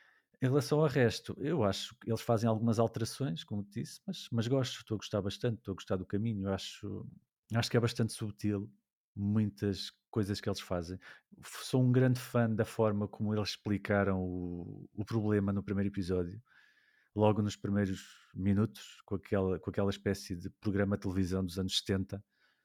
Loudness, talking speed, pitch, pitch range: -34 LUFS, 180 wpm, 105 Hz, 100-115 Hz